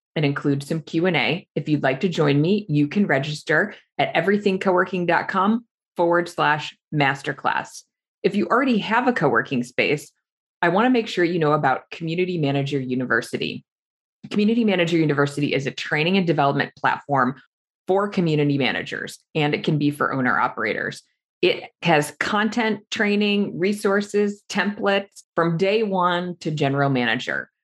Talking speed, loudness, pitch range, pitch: 145 wpm, -21 LUFS, 145-200 Hz, 170 Hz